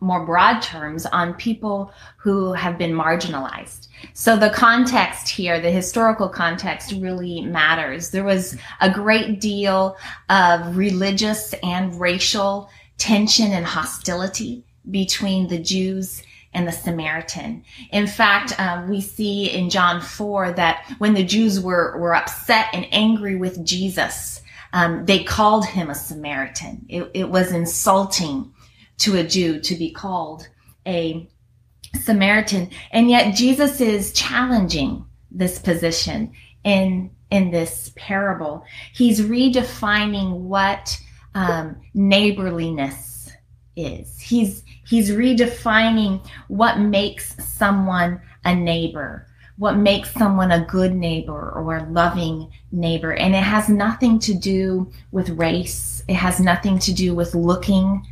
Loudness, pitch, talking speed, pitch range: -19 LUFS, 185 Hz, 125 wpm, 170-205 Hz